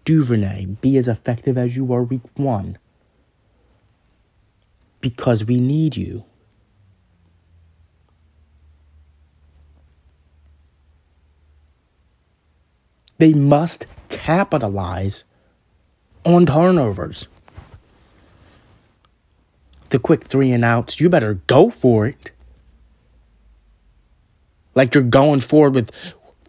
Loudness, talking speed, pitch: -17 LUFS, 75 wpm, 100 Hz